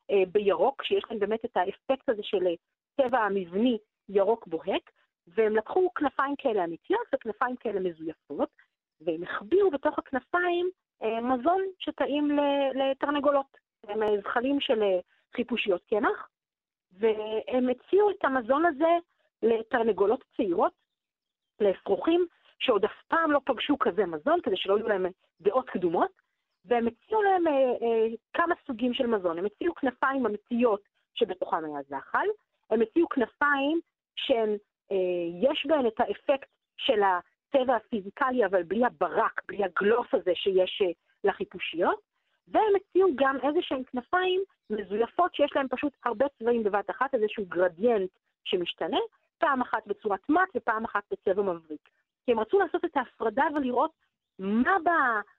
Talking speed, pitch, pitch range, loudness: 135 wpm, 250 Hz, 205-300 Hz, -28 LUFS